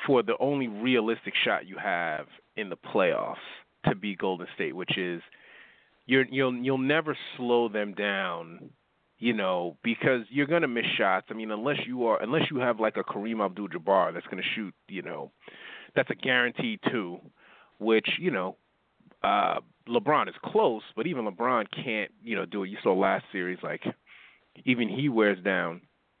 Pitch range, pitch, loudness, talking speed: 105-135 Hz, 120 Hz, -28 LUFS, 175 wpm